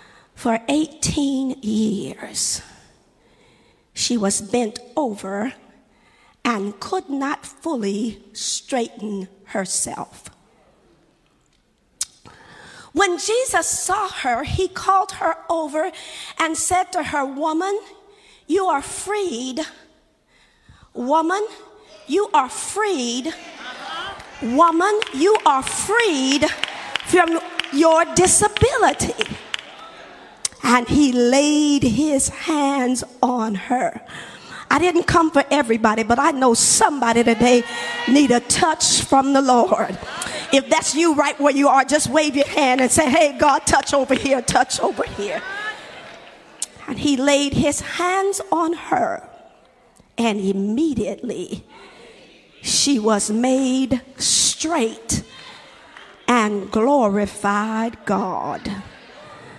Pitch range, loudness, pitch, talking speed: 240-340 Hz, -19 LUFS, 285 Hz, 100 wpm